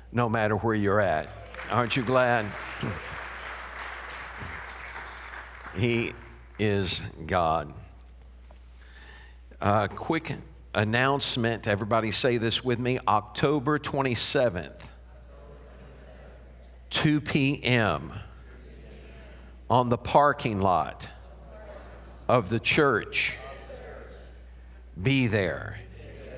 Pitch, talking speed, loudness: 105 Hz, 75 wpm, -26 LUFS